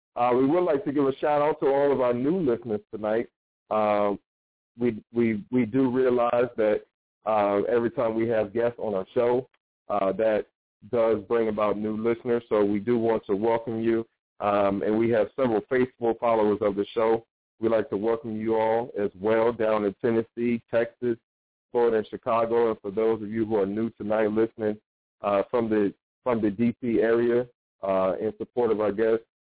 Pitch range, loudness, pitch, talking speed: 105-120 Hz, -26 LUFS, 115 Hz, 190 wpm